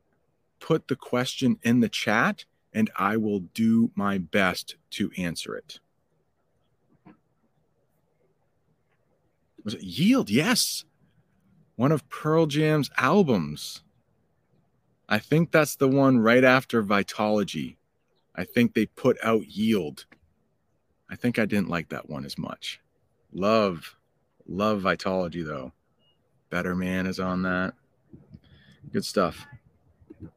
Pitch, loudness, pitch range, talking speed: 110 Hz, -25 LUFS, 95-150 Hz, 115 wpm